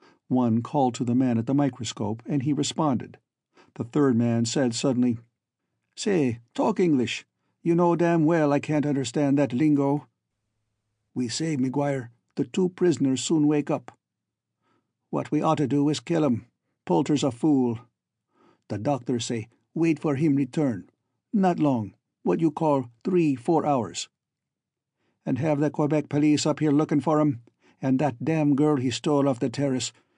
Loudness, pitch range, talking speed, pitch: -25 LUFS, 125-150 Hz, 160 wpm, 140 Hz